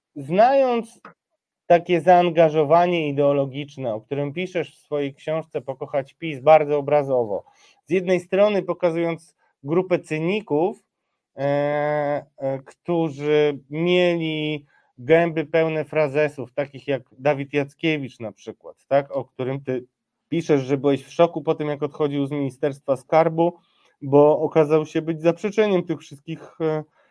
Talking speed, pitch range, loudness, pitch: 125 wpm, 145-170 Hz, -22 LUFS, 155 Hz